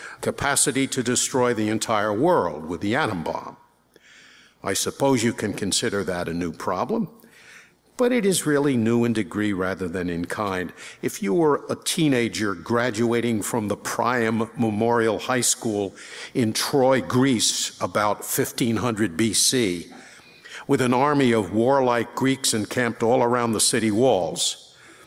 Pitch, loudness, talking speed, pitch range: 120 Hz, -22 LUFS, 145 wpm, 110-130 Hz